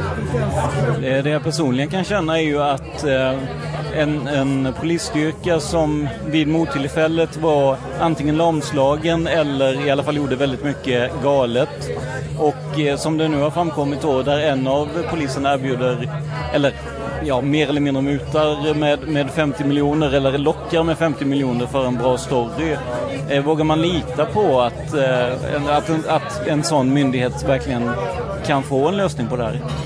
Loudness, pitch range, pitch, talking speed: -19 LUFS, 135-155 Hz, 145 Hz, 150 wpm